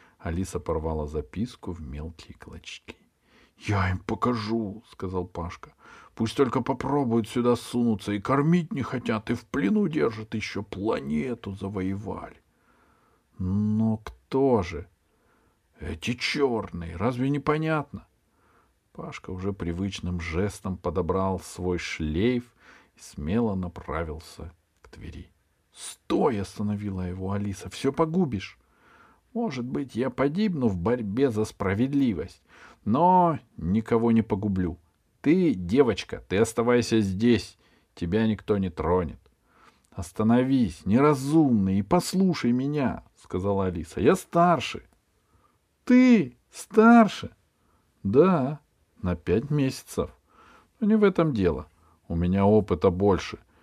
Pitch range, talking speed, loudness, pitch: 90-125 Hz, 110 wpm, -26 LUFS, 105 Hz